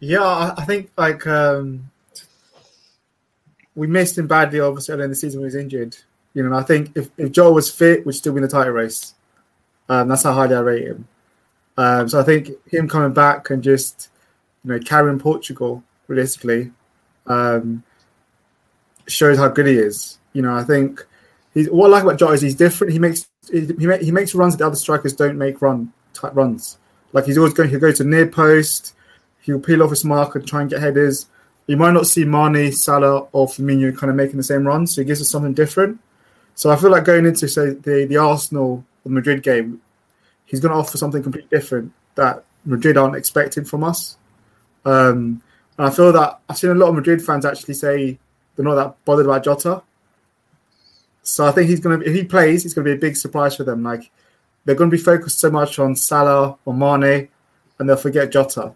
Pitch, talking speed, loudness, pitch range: 145 Hz, 215 wpm, -16 LUFS, 135-155 Hz